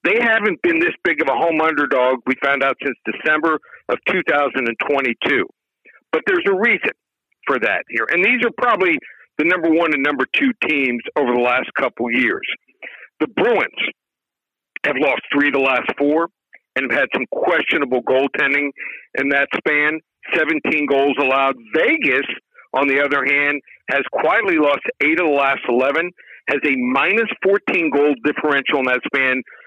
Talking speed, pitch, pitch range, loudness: 165 wpm, 145 Hz, 135-165 Hz, -17 LUFS